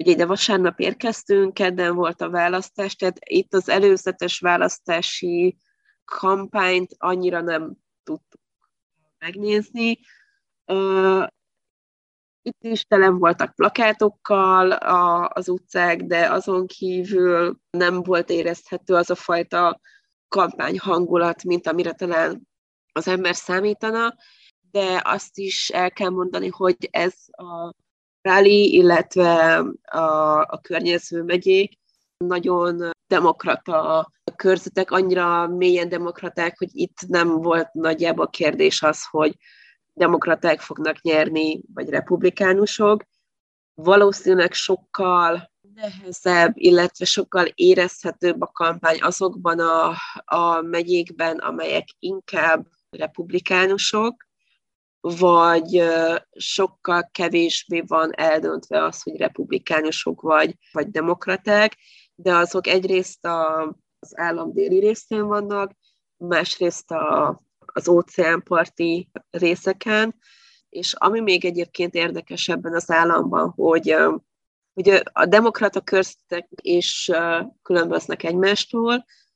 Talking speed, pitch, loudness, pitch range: 100 wpm, 180 Hz, -20 LUFS, 170-195 Hz